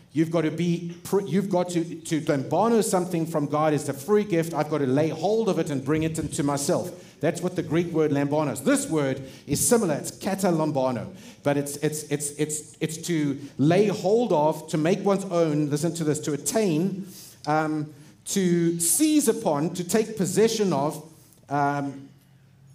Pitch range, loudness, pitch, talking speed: 150-180 Hz, -25 LUFS, 160 Hz, 180 wpm